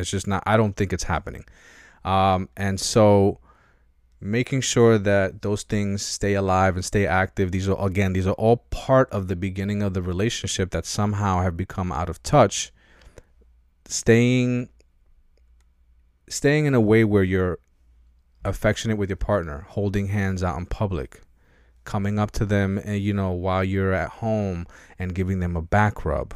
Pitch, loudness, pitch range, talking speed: 95 Hz, -23 LUFS, 90-105 Hz, 170 wpm